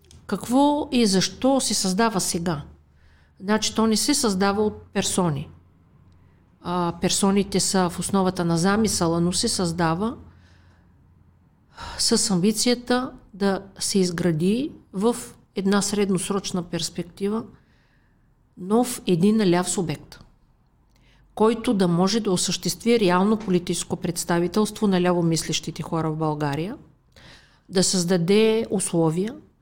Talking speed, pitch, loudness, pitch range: 105 wpm, 185 Hz, -22 LUFS, 170-215 Hz